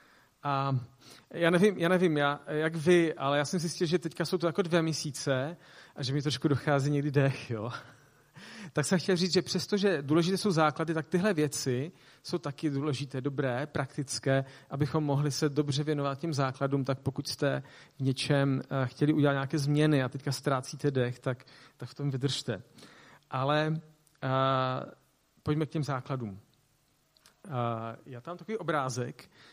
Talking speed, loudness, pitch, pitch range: 165 wpm, -30 LUFS, 145 Hz, 135-160 Hz